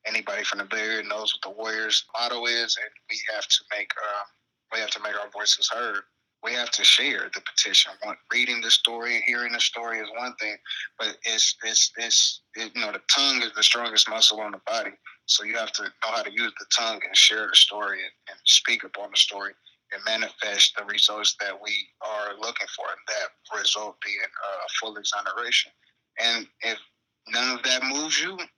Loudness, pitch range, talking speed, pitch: -22 LUFS, 105-120 Hz, 210 wpm, 115 Hz